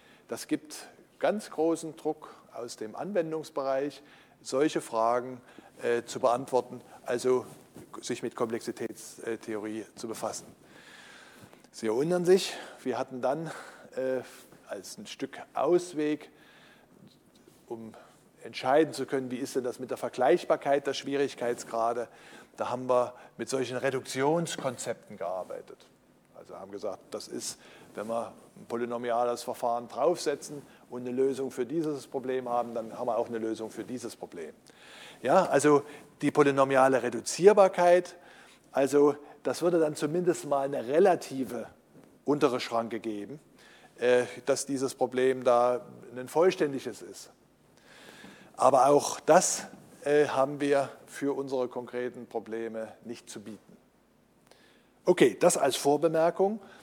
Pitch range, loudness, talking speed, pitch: 120-150 Hz, -29 LUFS, 120 wpm, 130 Hz